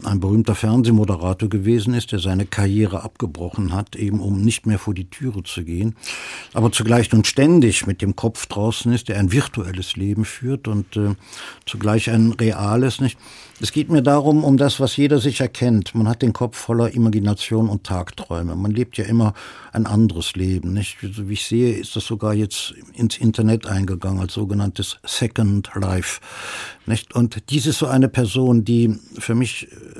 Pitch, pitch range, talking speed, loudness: 110 Hz, 100-120 Hz, 180 wpm, -20 LUFS